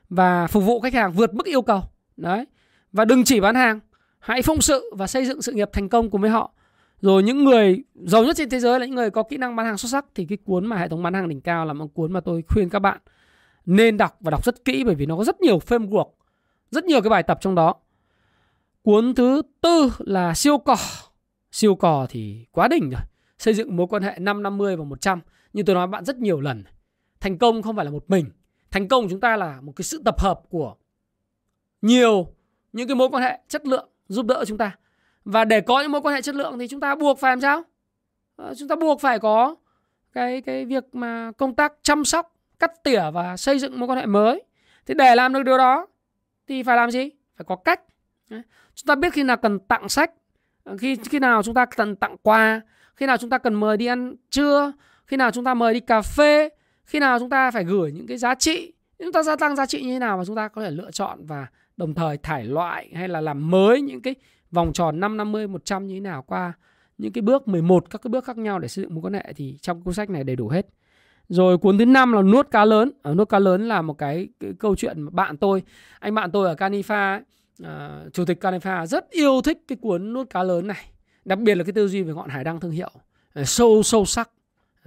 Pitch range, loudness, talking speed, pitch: 180-255 Hz, -21 LUFS, 250 wpm, 220 Hz